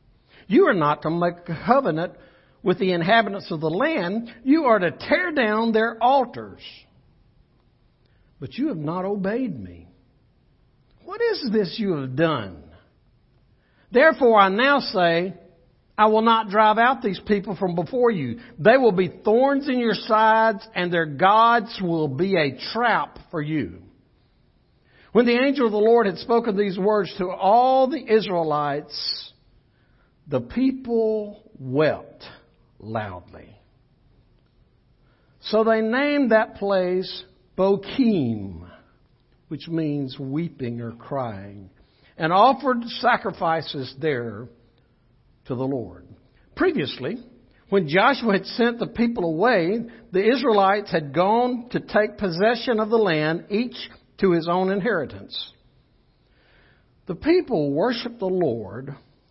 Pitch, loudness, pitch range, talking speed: 190 Hz, -21 LUFS, 145-225 Hz, 125 wpm